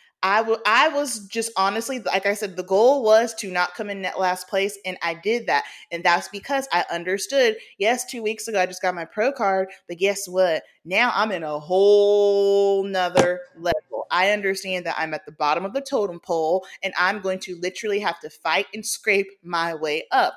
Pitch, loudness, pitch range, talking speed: 195 Hz, -22 LUFS, 180-215 Hz, 210 wpm